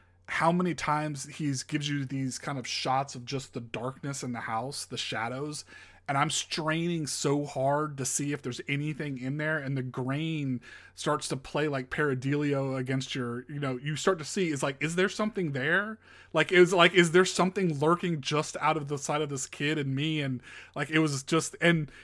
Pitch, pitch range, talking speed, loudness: 145 Hz, 135-155 Hz, 210 wpm, -29 LUFS